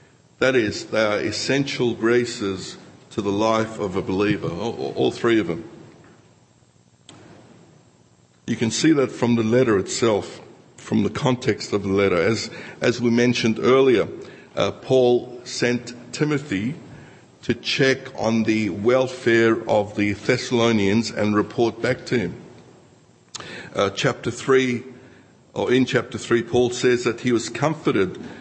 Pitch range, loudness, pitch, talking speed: 110-125 Hz, -21 LUFS, 120 Hz, 135 wpm